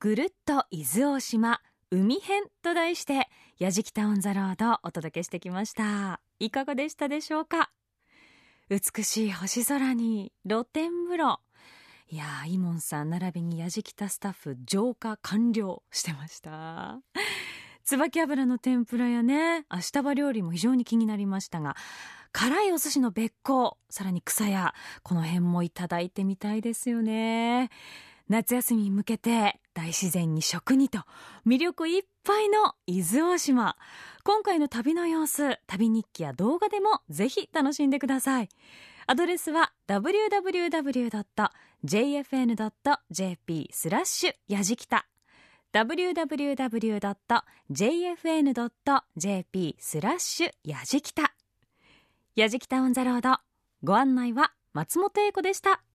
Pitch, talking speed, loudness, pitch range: 235 Hz, 245 characters per minute, -28 LUFS, 195-290 Hz